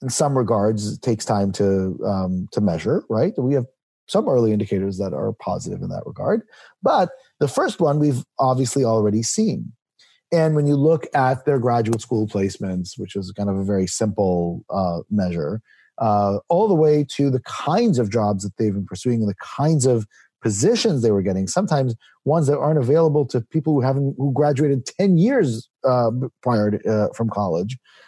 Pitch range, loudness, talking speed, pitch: 100-140 Hz, -21 LUFS, 190 wpm, 120 Hz